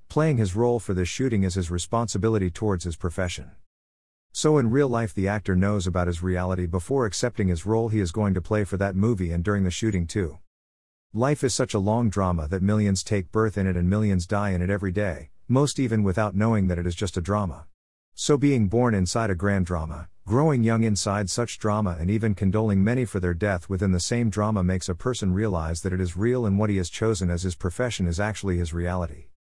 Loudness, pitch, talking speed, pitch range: -25 LUFS, 100 Hz, 225 wpm, 90-110 Hz